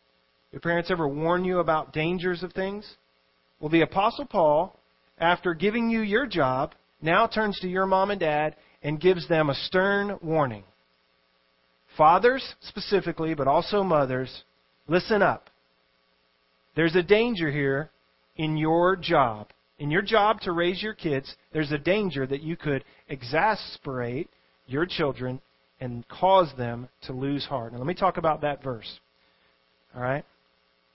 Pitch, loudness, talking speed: 155 Hz, -25 LUFS, 145 wpm